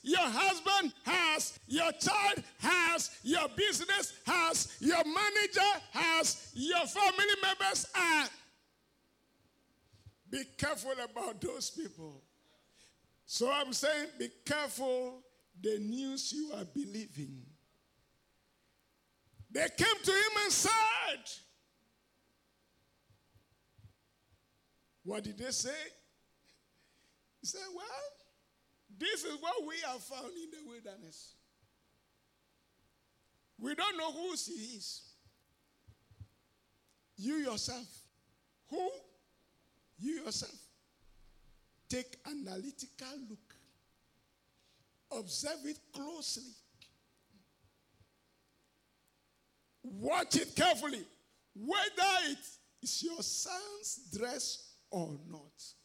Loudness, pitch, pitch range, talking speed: -34 LUFS, 285 Hz, 220-345 Hz, 85 wpm